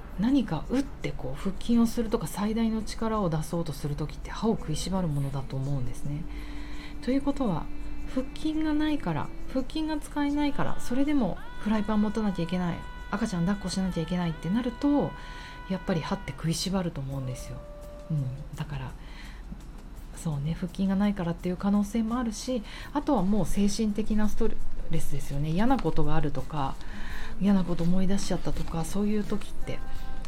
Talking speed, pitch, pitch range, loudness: 390 characters per minute, 185 Hz, 155-225 Hz, -30 LUFS